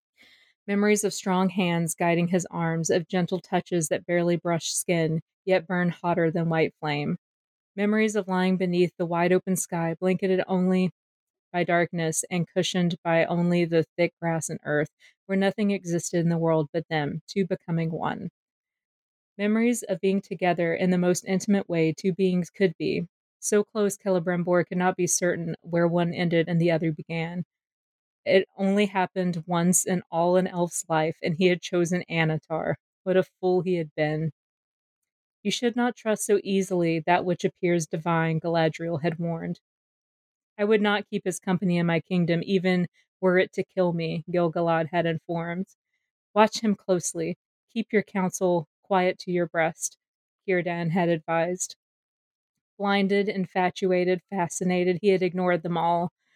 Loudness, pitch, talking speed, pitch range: -26 LUFS, 180 Hz, 160 wpm, 170-190 Hz